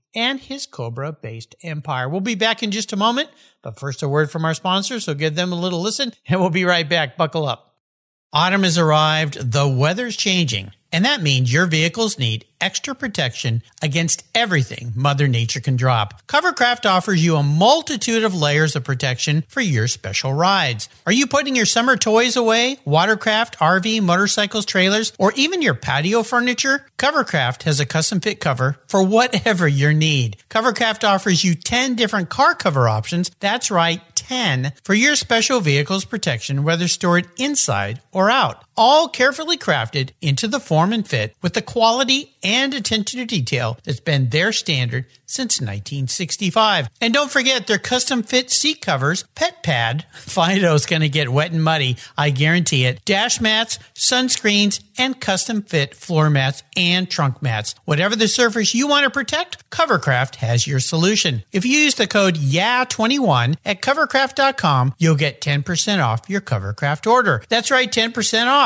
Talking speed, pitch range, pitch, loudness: 170 wpm, 145-230 Hz, 180 Hz, -18 LUFS